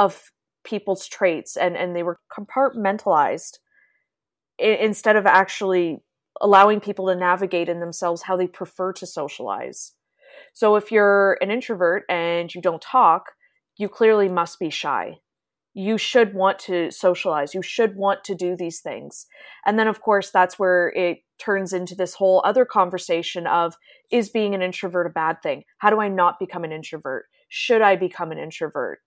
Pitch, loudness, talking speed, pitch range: 190 Hz, -21 LUFS, 165 wpm, 175-210 Hz